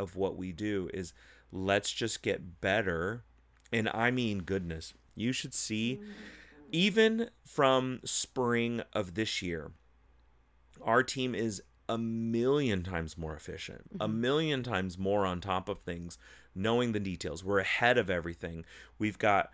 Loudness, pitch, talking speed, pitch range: -32 LUFS, 100 Hz, 145 wpm, 85-120 Hz